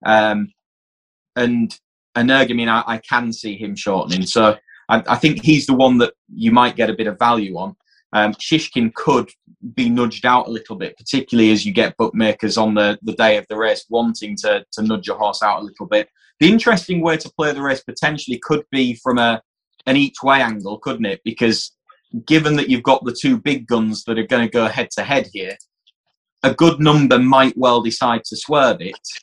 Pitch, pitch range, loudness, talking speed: 120 Hz, 110-145 Hz, -17 LUFS, 210 wpm